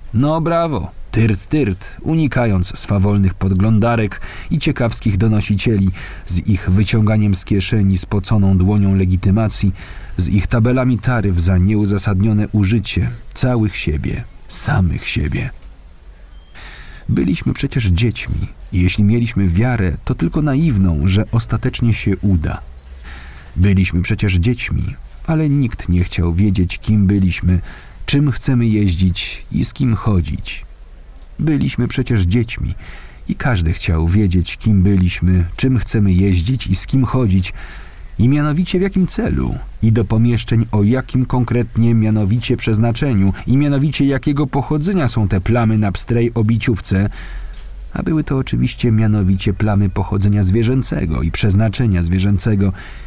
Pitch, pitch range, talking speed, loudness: 105 Hz, 95-120 Hz, 125 wpm, -16 LUFS